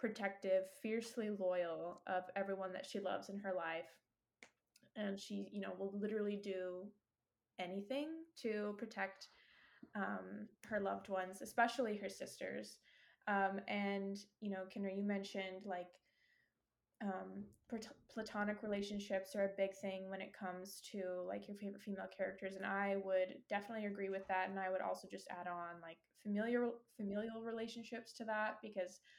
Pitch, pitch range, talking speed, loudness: 200 Hz, 190-215 Hz, 150 wpm, -44 LUFS